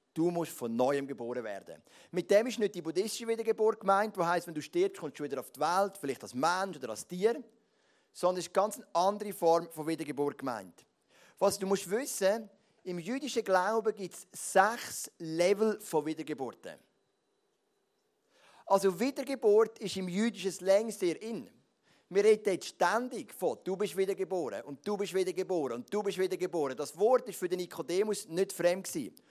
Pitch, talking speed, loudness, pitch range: 195 Hz, 180 wpm, -32 LUFS, 170-215 Hz